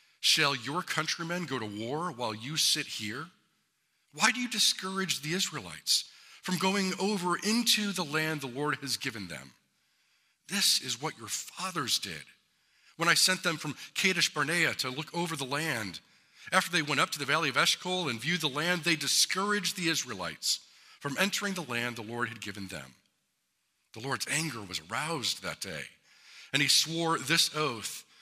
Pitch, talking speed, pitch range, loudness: 160 Hz, 175 wpm, 135-180 Hz, -29 LUFS